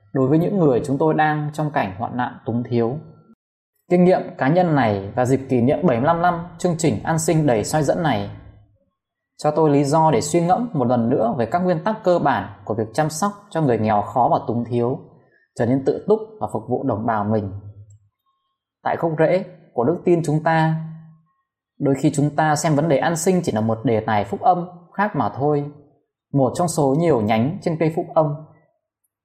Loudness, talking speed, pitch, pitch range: -20 LUFS, 215 wpm, 150 Hz, 120-170 Hz